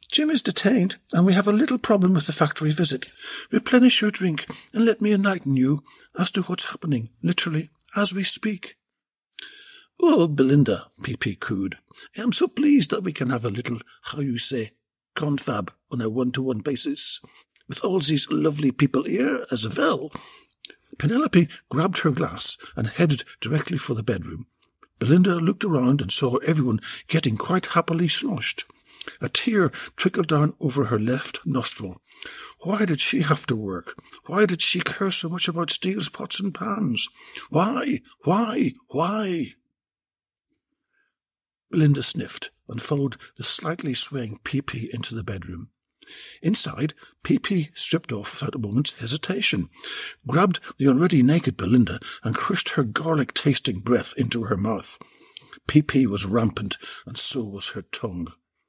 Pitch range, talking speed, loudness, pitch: 125-185 Hz, 155 wpm, -20 LUFS, 150 Hz